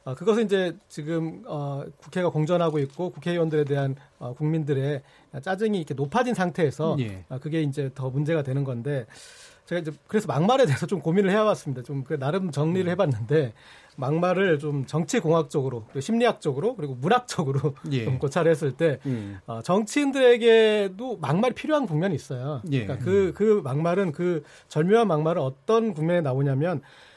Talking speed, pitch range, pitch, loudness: 370 characters per minute, 140-190 Hz, 160 Hz, -25 LUFS